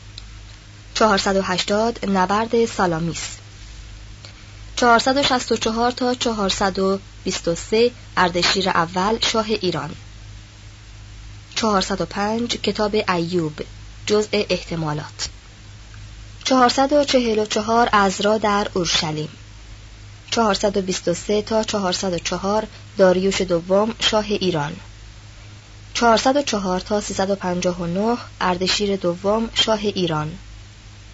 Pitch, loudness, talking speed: 185 Hz, -20 LUFS, 65 wpm